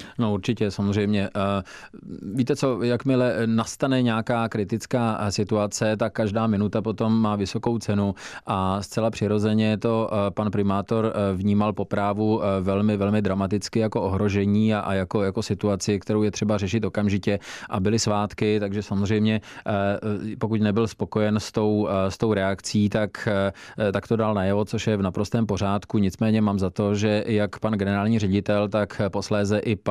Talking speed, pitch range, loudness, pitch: 150 wpm, 100-110 Hz, -24 LUFS, 105 Hz